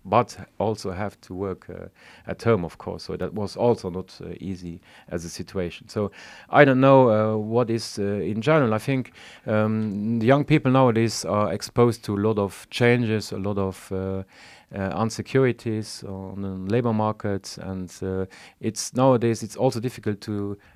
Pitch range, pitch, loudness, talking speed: 95-115 Hz, 110 Hz, -24 LUFS, 180 wpm